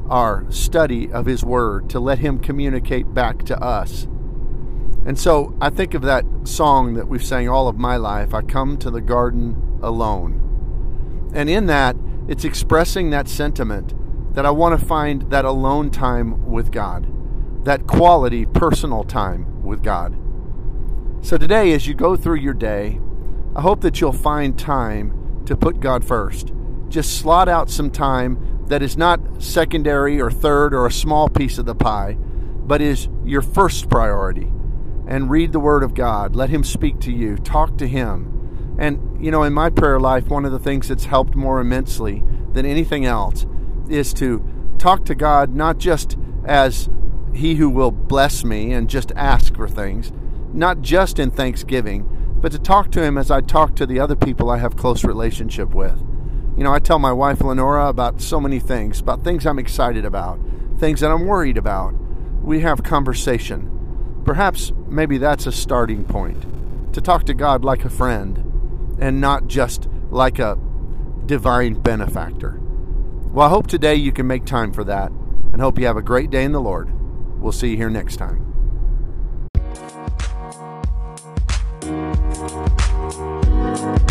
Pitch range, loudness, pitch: 105-145 Hz, -19 LUFS, 125 Hz